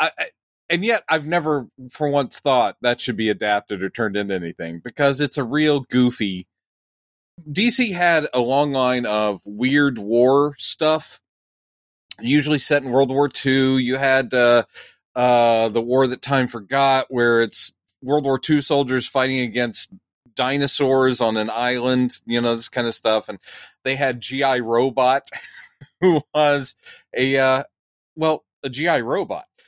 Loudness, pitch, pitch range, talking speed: -20 LUFS, 130 Hz, 120-145 Hz, 155 wpm